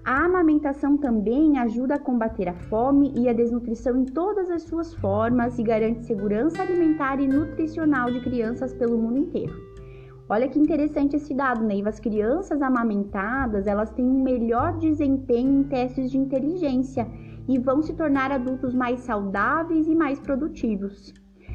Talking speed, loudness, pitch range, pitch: 155 wpm, -23 LUFS, 230-290 Hz, 260 Hz